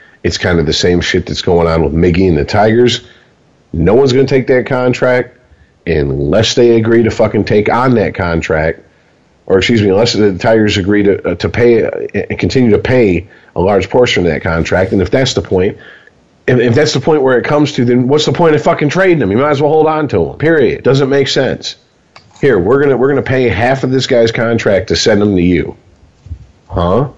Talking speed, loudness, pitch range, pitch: 230 wpm, -11 LUFS, 100-135 Hz, 120 Hz